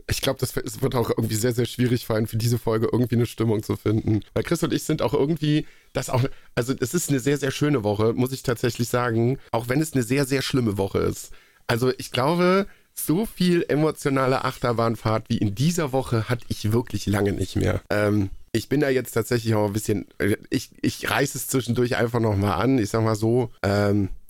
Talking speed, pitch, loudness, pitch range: 215 wpm, 120 Hz, -24 LUFS, 110-135 Hz